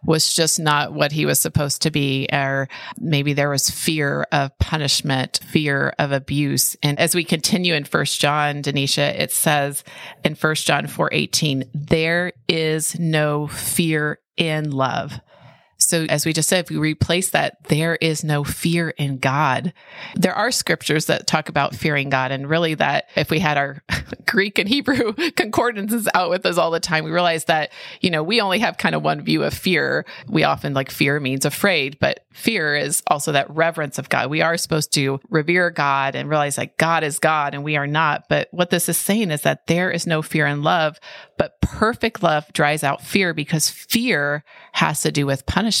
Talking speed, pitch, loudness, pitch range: 195 wpm, 155 Hz, -19 LUFS, 145-170 Hz